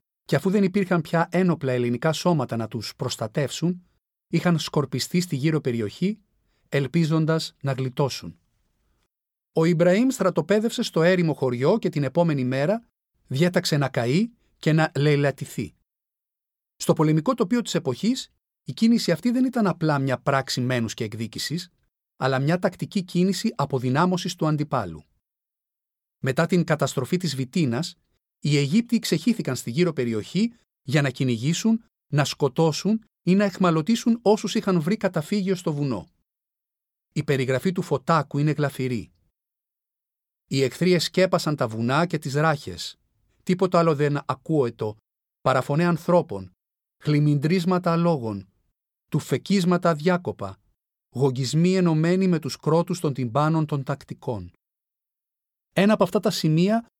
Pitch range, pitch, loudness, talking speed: 130-180 Hz, 155 Hz, -23 LUFS, 130 wpm